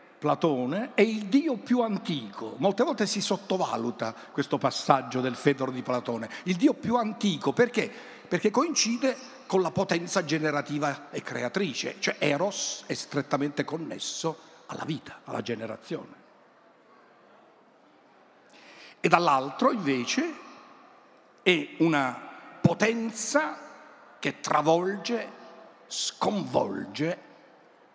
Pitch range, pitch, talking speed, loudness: 145-235 Hz, 185 Hz, 100 wpm, -28 LUFS